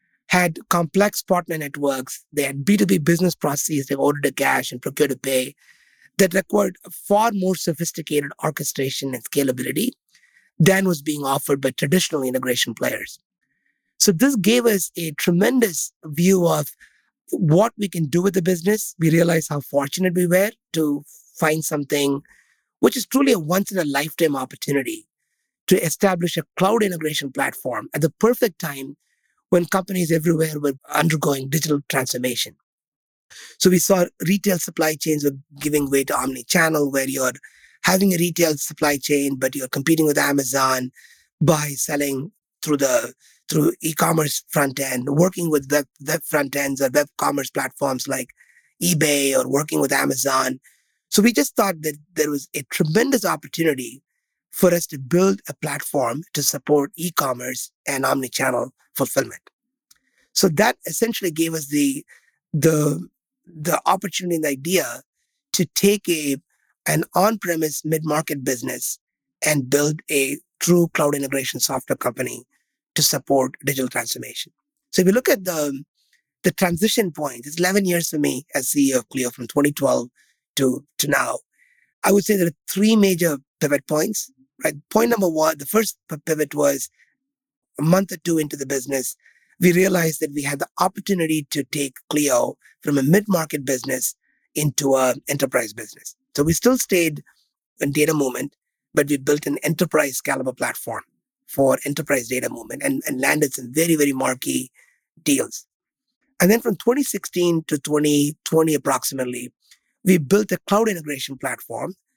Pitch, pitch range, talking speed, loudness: 155 Hz, 140-185 Hz, 155 wpm, -21 LUFS